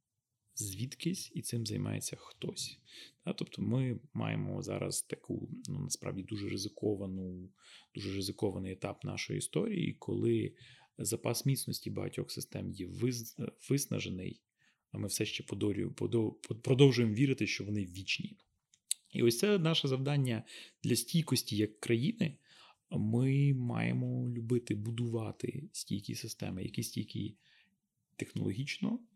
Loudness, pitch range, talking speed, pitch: -36 LUFS, 105-135 Hz, 110 wpm, 115 Hz